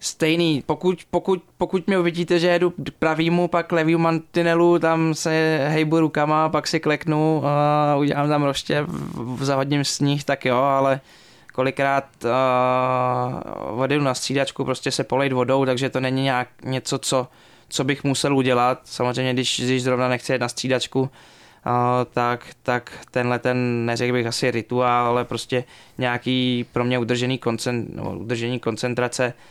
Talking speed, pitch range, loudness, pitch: 155 wpm, 125-155 Hz, -21 LUFS, 130 Hz